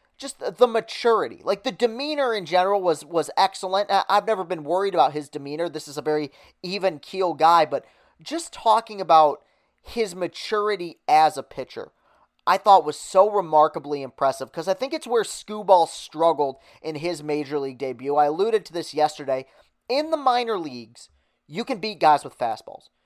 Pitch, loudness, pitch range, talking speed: 180 Hz, -23 LUFS, 150-215 Hz, 175 wpm